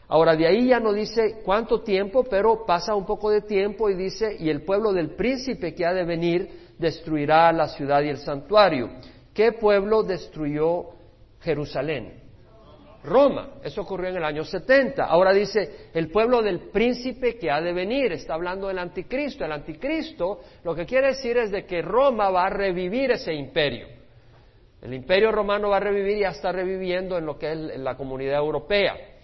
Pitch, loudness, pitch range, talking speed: 190 Hz, -23 LUFS, 165-215 Hz, 180 wpm